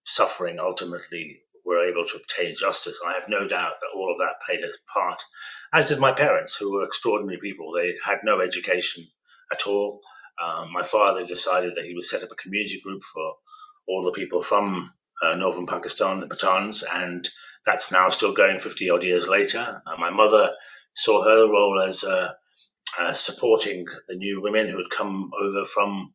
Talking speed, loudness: 185 wpm, -22 LUFS